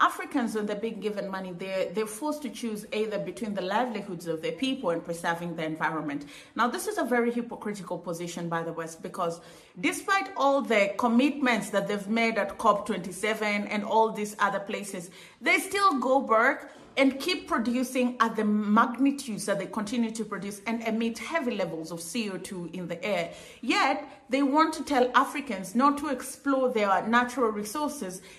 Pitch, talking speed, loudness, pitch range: 220 Hz, 175 wpm, -28 LUFS, 195-265 Hz